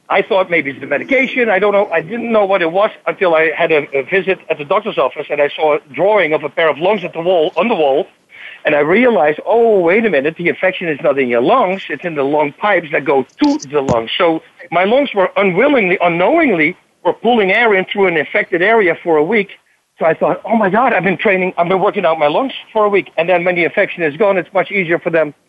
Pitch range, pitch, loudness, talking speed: 160-205 Hz, 185 Hz, -14 LUFS, 265 wpm